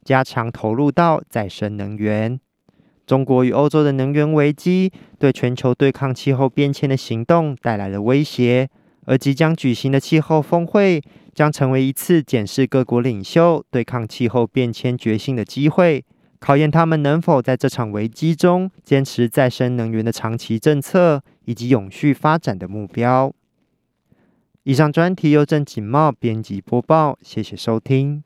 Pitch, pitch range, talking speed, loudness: 135 Hz, 120-150 Hz, 245 characters per minute, -18 LUFS